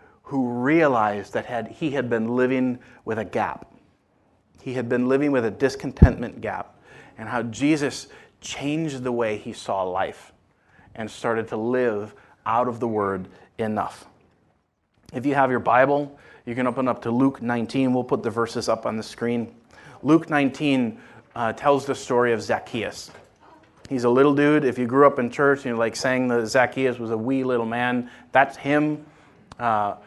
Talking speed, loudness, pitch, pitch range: 180 wpm, -23 LUFS, 125 Hz, 115-135 Hz